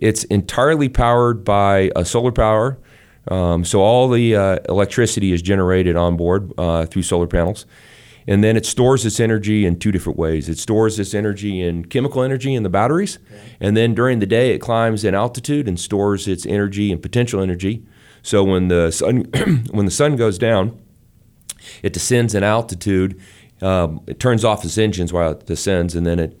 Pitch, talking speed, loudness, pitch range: 105 Hz, 185 wpm, -17 LUFS, 95-115 Hz